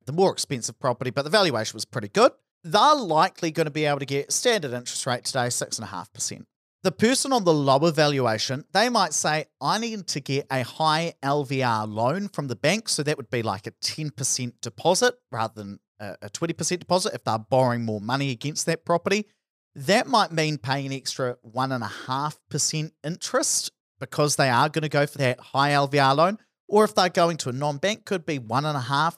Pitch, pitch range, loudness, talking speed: 145 Hz, 130-170 Hz, -24 LUFS, 195 wpm